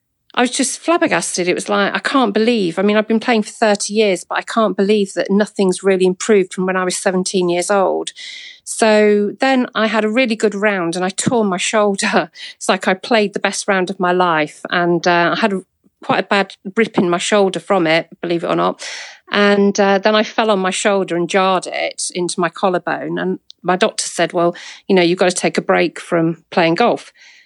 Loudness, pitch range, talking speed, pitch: -16 LUFS, 180-220 Hz, 225 wpm, 200 Hz